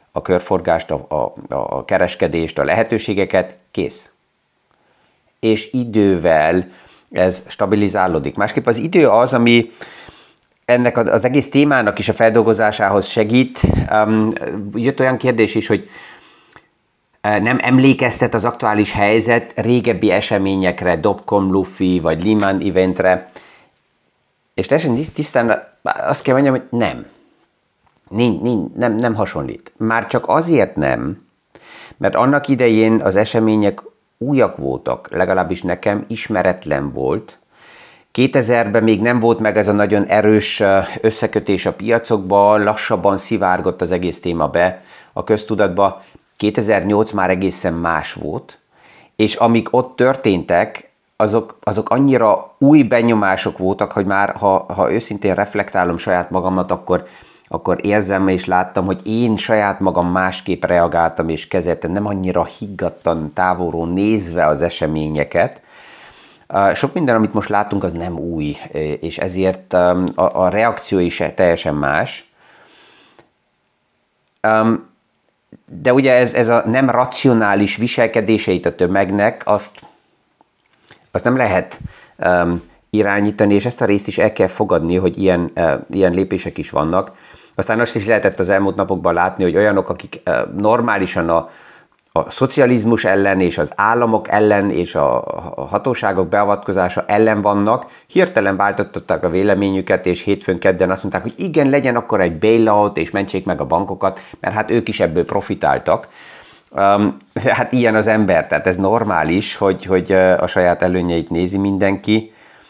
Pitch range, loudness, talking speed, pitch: 90-110 Hz, -16 LUFS, 130 wpm, 100 Hz